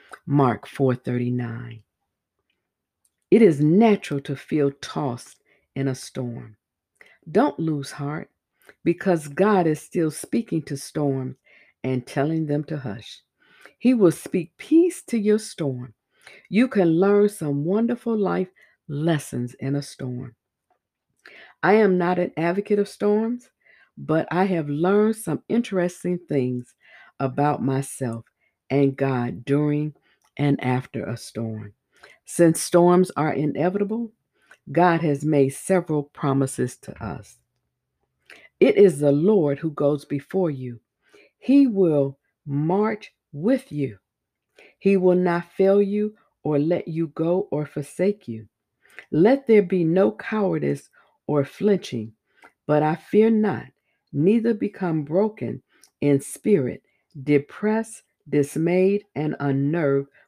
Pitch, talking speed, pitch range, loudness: 155 Hz, 125 wpm, 140-195 Hz, -22 LUFS